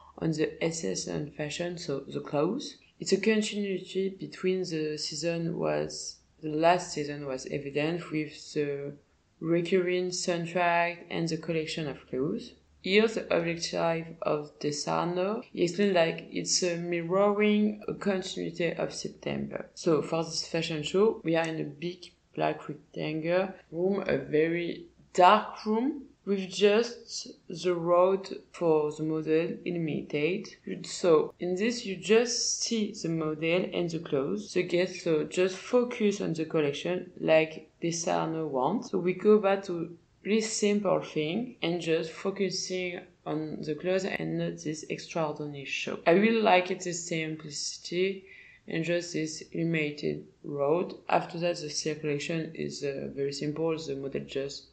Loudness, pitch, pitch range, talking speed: -30 LUFS, 170 Hz, 155-190 Hz, 145 wpm